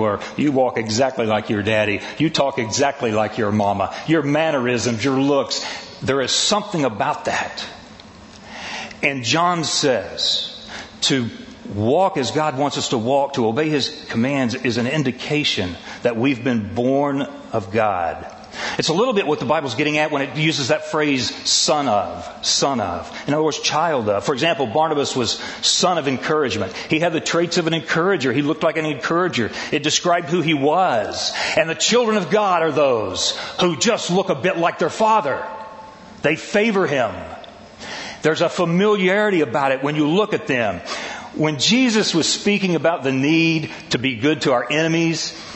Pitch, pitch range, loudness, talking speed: 150 Hz, 130-170 Hz, -19 LUFS, 175 wpm